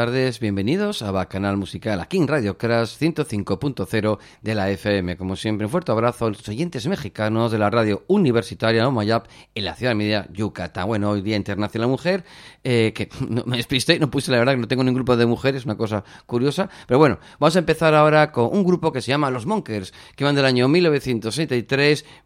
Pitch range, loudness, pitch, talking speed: 105-145 Hz, -21 LUFS, 120 Hz, 215 wpm